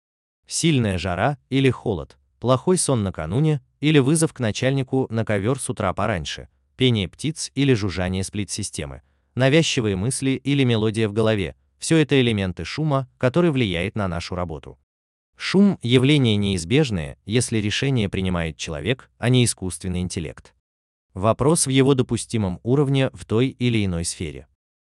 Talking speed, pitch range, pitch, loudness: 135 wpm, 90-135 Hz, 110 Hz, -21 LUFS